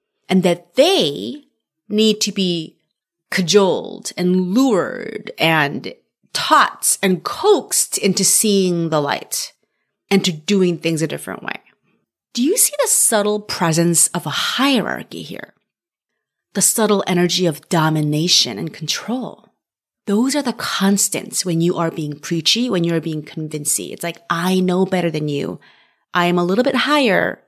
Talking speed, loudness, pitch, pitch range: 145 wpm, -17 LUFS, 185 Hz, 165-215 Hz